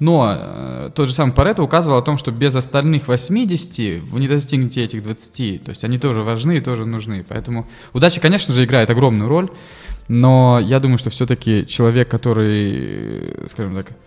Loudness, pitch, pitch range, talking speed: -17 LUFS, 125 Hz, 115-150 Hz, 175 wpm